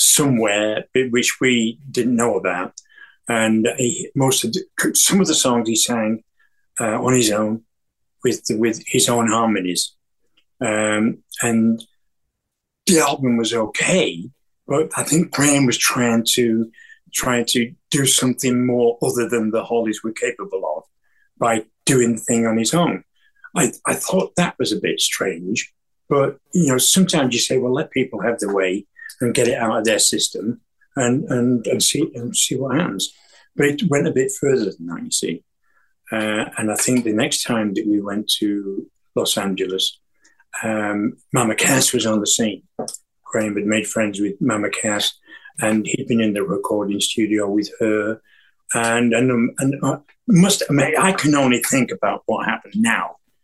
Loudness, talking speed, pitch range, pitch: -19 LUFS, 175 wpm, 110-135 Hz, 120 Hz